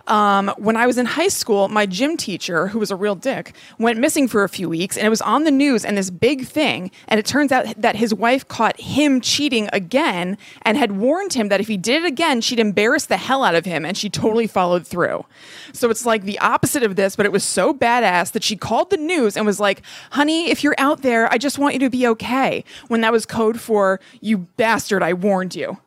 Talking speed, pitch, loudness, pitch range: 245 wpm, 225 Hz, -18 LUFS, 200-265 Hz